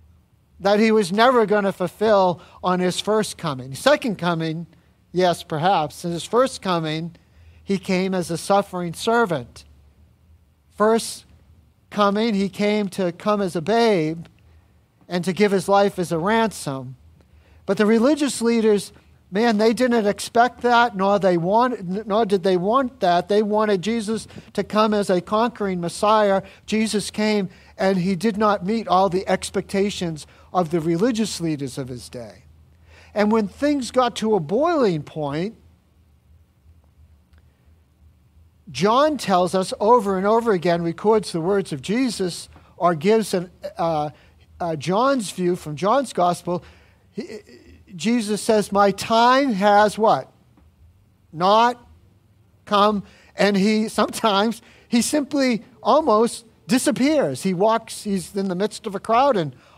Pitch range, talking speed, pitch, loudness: 160-220 Hz, 140 wpm, 195 Hz, -20 LUFS